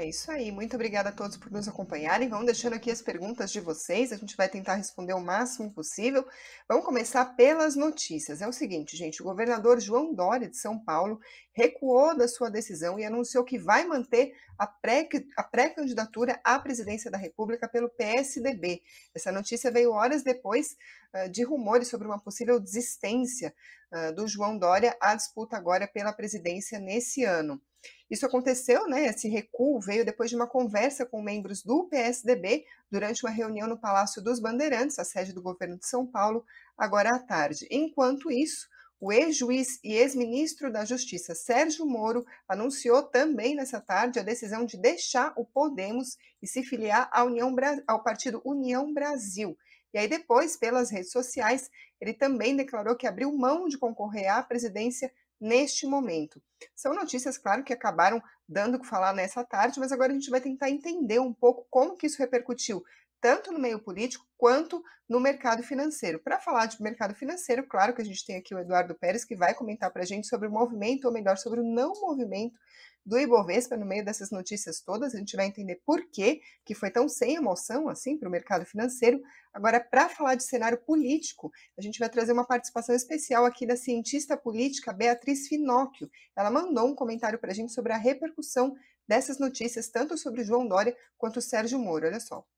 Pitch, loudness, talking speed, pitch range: 240 Hz, -29 LUFS, 185 wpm, 210-260 Hz